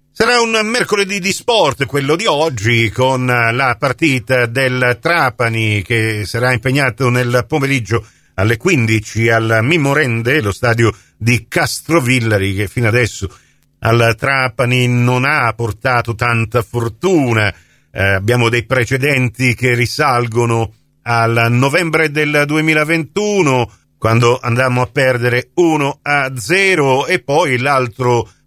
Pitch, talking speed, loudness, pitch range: 125 Hz, 115 wpm, -14 LUFS, 115-140 Hz